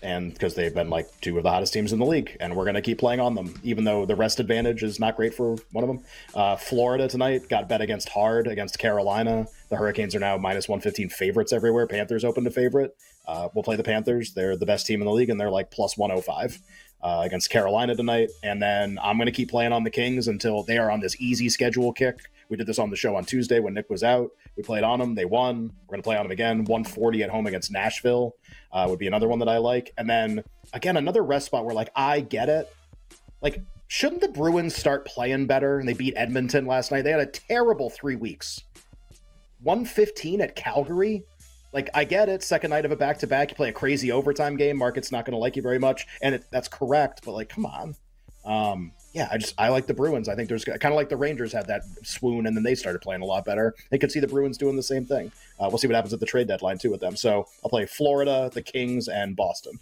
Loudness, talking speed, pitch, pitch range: -25 LUFS, 250 wpm, 120 Hz, 110-140 Hz